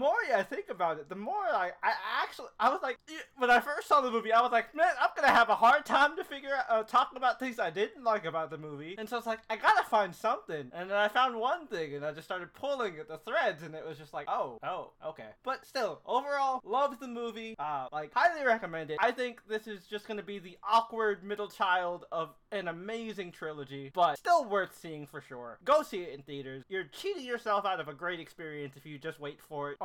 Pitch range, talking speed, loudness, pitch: 160-250 Hz, 255 wpm, -31 LUFS, 210 Hz